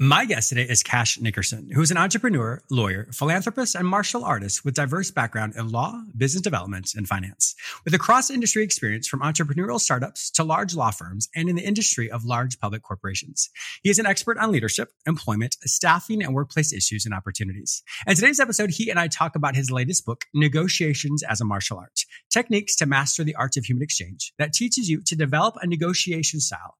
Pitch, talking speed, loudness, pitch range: 145 Hz, 195 wpm, -22 LUFS, 115-180 Hz